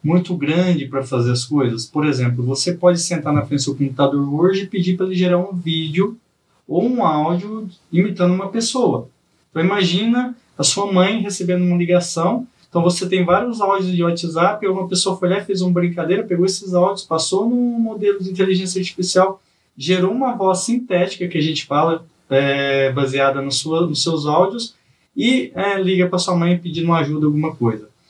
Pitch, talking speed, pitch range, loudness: 180 Hz, 185 wpm, 155-190 Hz, -18 LUFS